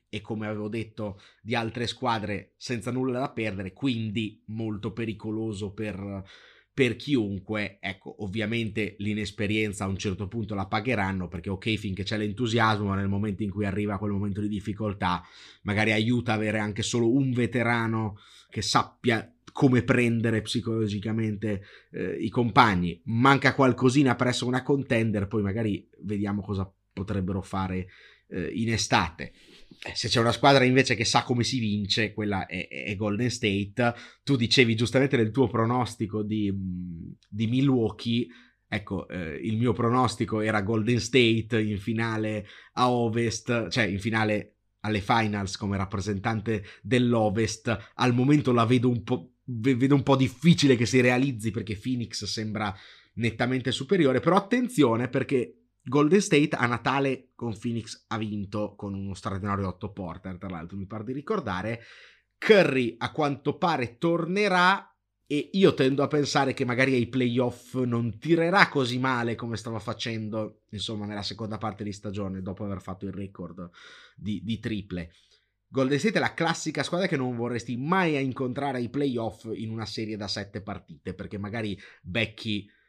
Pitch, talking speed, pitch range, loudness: 110 Hz, 155 wpm, 105-125 Hz, -27 LUFS